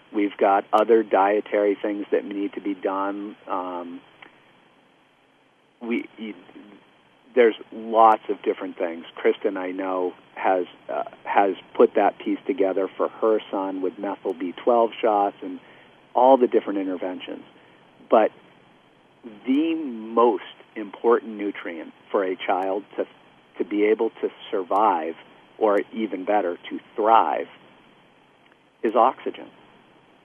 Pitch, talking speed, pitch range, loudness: 105 Hz, 120 wpm, 95-115 Hz, -23 LUFS